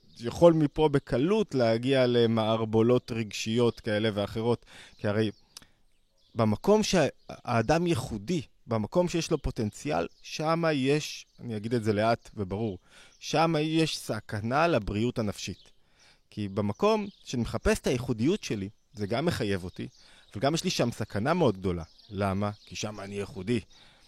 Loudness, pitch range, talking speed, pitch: -28 LUFS, 105-150 Hz, 130 wpm, 115 Hz